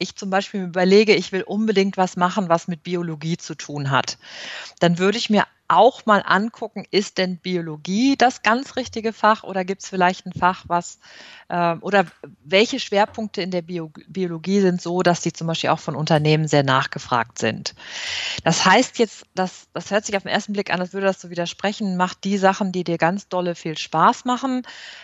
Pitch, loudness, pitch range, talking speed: 185 Hz, -21 LUFS, 175-205 Hz, 200 wpm